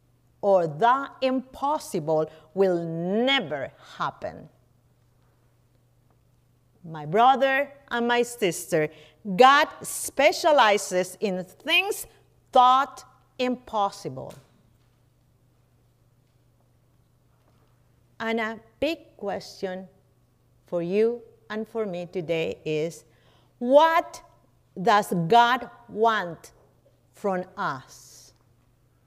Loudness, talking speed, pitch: -24 LUFS, 70 wpm, 180 Hz